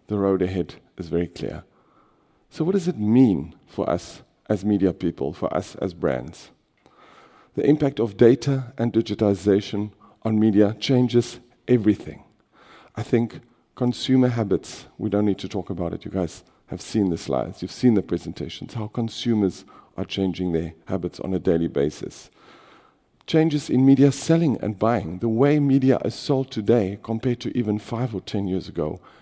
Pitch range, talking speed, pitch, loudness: 95-125 Hz, 165 wpm, 105 Hz, -23 LUFS